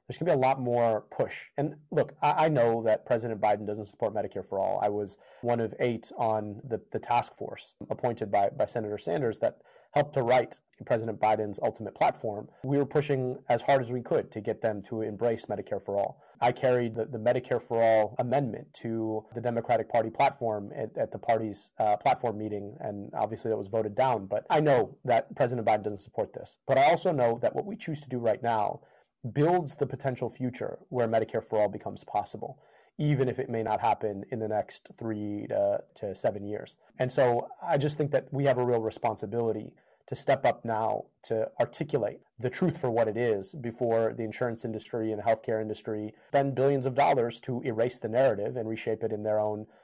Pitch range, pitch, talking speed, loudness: 110-130 Hz, 115 Hz, 205 wpm, -29 LUFS